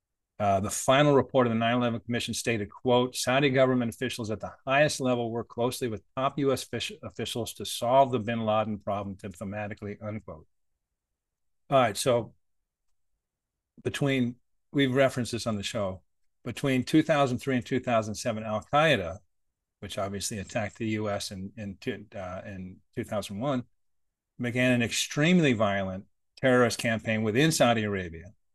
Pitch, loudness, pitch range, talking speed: 110 Hz, -27 LUFS, 100-125 Hz, 140 wpm